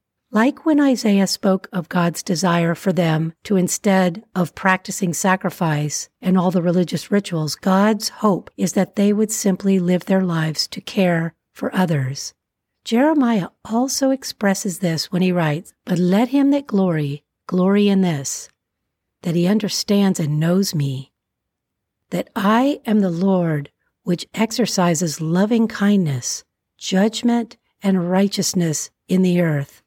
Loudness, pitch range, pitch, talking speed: -19 LUFS, 170-205 Hz, 185 Hz, 140 wpm